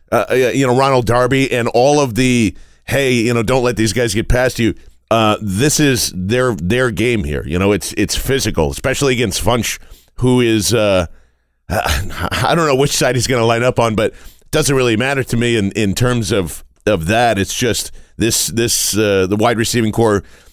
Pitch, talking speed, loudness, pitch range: 115 Hz, 205 wpm, -15 LUFS, 100-125 Hz